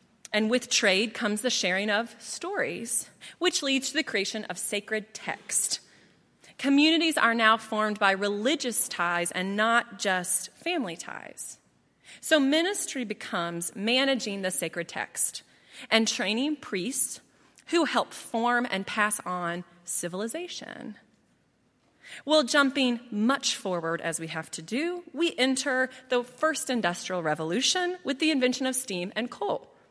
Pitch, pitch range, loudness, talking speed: 230 Hz, 195-270 Hz, -27 LUFS, 135 wpm